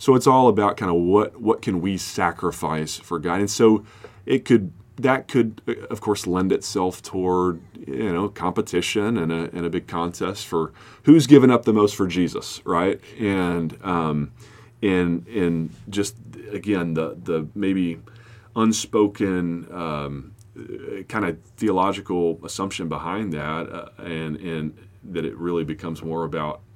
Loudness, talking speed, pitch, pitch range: -22 LUFS, 155 wpm, 90 Hz, 85-110 Hz